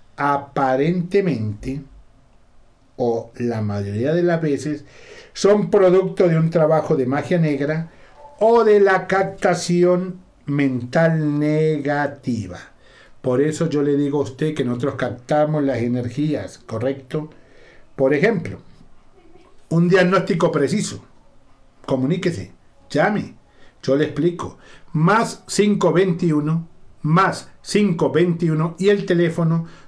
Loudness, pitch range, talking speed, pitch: -19 LUFS, 140-185 Hz, 100 wpm, 155 Hz